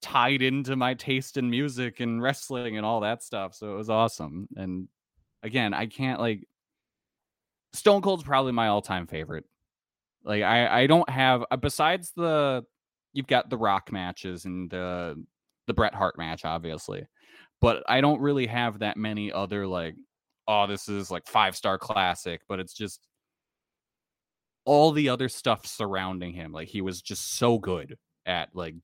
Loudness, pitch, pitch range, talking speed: -27 LUFS, 110 Hz, 95-130 Hz, 165 wpm